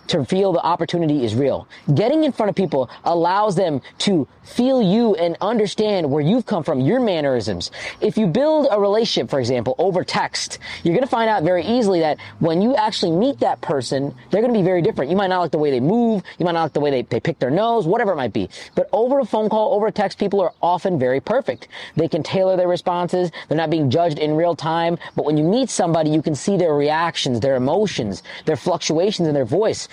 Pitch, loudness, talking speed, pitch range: 175 Hz, -19 LUFS, 235 wpm, 160-210 Hz